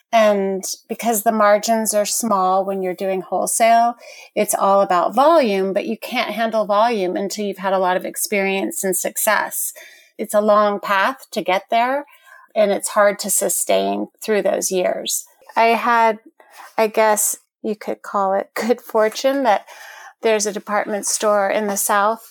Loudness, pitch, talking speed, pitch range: -18 LUFS, 210 Hz, 165 wpm, 195-225 Hz